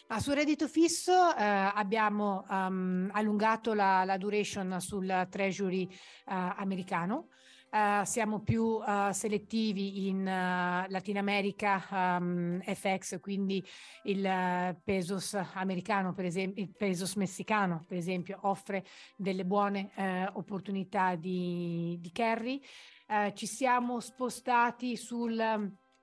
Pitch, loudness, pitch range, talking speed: 195 Hz, -32 LUFS, 185-210 Hz, 120 wpm